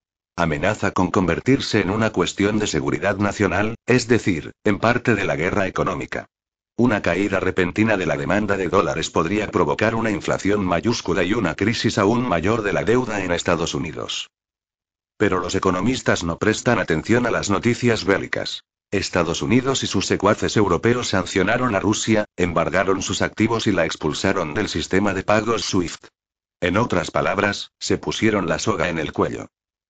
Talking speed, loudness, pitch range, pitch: 165 wpm, -20 LUFS, 90-110 Hz, 100 Hz